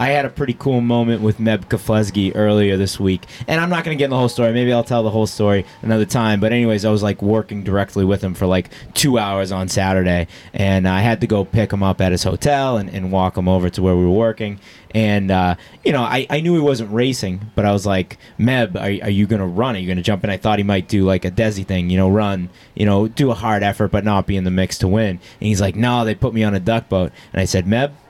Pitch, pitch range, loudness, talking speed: 105 Hz, 95-115 Hz, -18 LUFS, 280 wpm